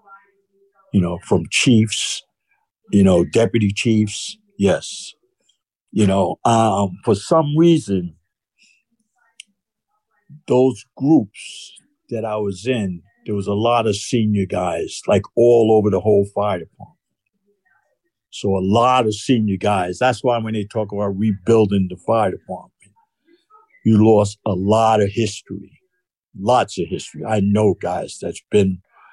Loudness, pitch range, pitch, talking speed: -18 LUFS, 100-165 Hz, 110 Hz, 135 wpm